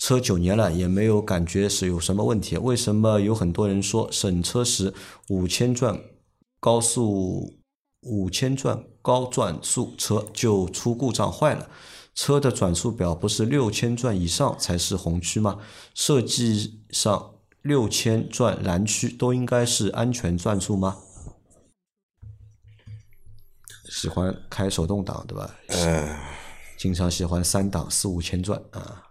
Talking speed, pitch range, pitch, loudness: 205 characters per minute, 95-120 Hz, 105 Hz, -24 LUFS